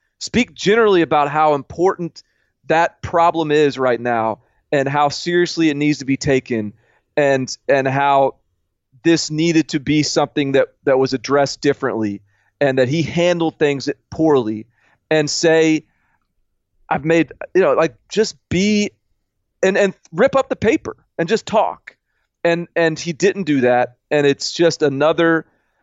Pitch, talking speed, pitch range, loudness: 150 Hz, 150 wpm, 135-165 Hz, -17 LUFS